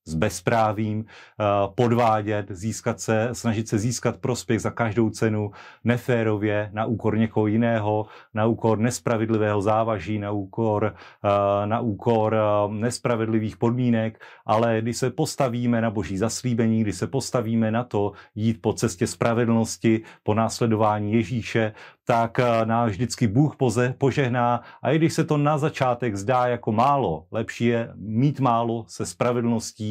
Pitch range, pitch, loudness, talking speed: 110-120 Hz, 115 Hz, -23 LUFS, 135 wpm